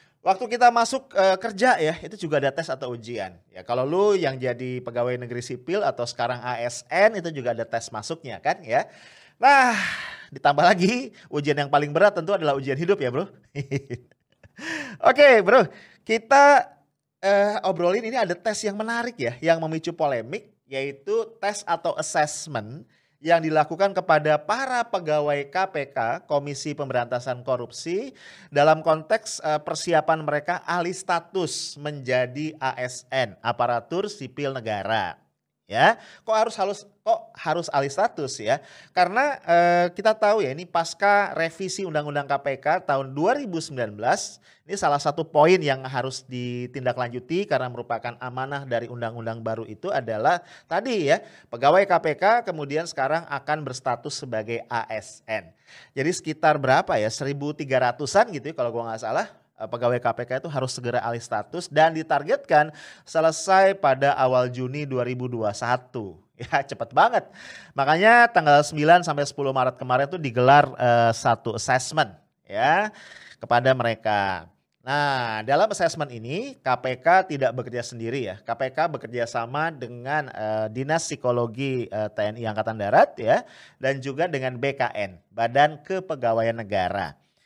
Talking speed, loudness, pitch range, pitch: 135 wpm, -23 LUFS, 125-170 Hz, 145 Hz